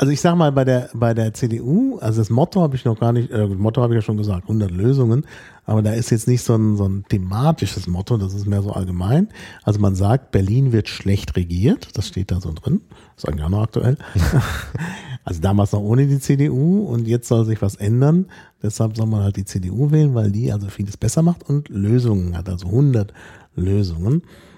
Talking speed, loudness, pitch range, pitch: 220 wpm, -19 LUFS, 100-130 Hz, 110 Hz